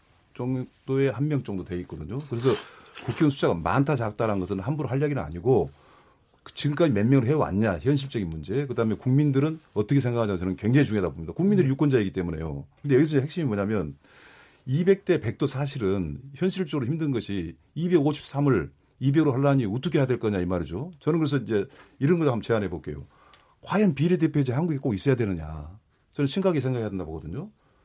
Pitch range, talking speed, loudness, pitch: 100-150 Hz, 415 characters per minute, -26 LUFS, 130 Hz